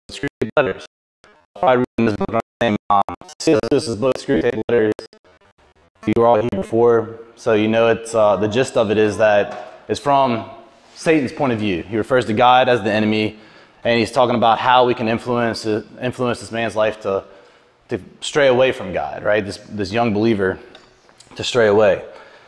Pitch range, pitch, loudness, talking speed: 105-120 Hz, 115 Hz, -18 LUFS, 175 wpm